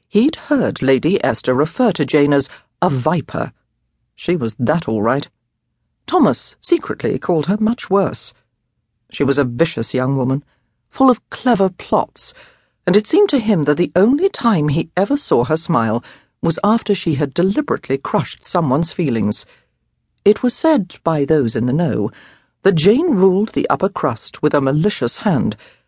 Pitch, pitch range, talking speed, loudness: 165 Hz, 135-215 Hz, 165 wpm, -17 LUFS